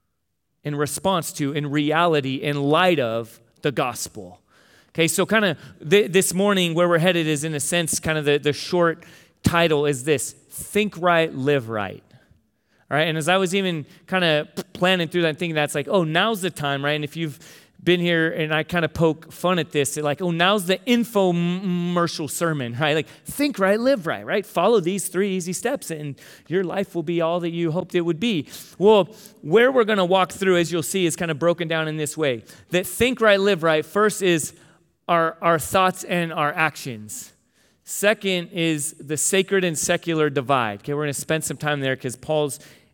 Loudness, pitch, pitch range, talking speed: -21 LUFS, 165 Hz, 150-185 Hz, 205 wpm